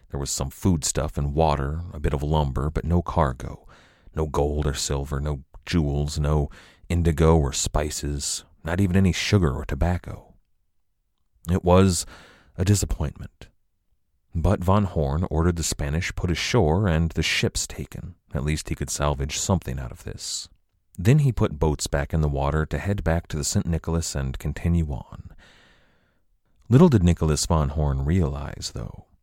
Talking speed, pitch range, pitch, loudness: 160 wpm, 75-90 Hz, 80 Hz, -24 LUFS